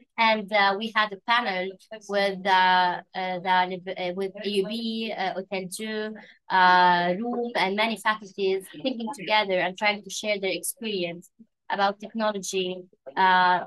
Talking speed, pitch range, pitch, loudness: 135 wpm, 185-215 Hz, 195 Hz, -25 LUFS